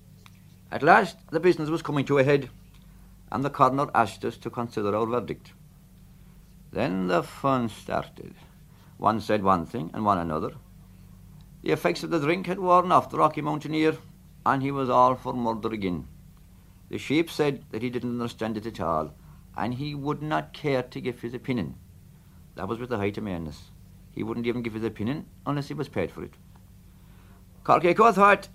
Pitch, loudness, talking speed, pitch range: 120 Hz, -26 LUFS, 180 wpm, 100-145 Hz